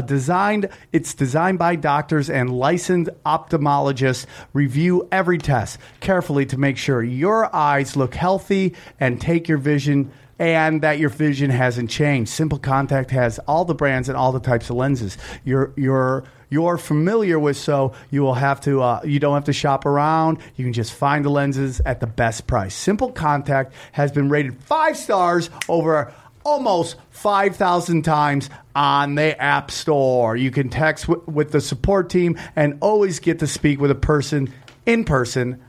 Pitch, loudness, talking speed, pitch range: 145 Hz, -20 LUFS, 170 wpm, 130-165 Hz